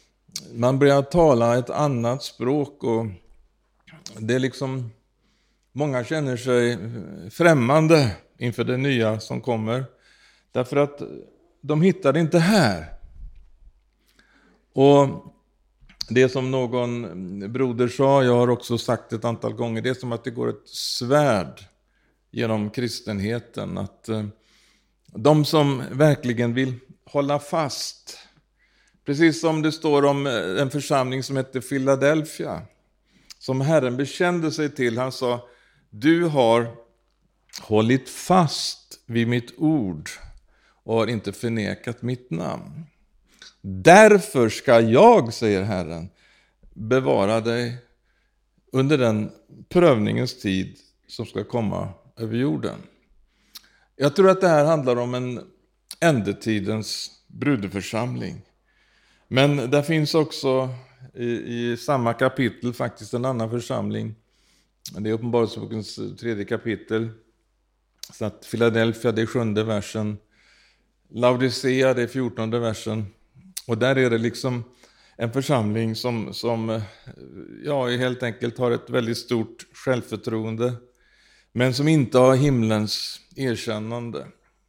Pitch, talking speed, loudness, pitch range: 125 Hz, 115 wpm, -22 LUFS, 115-140 Hz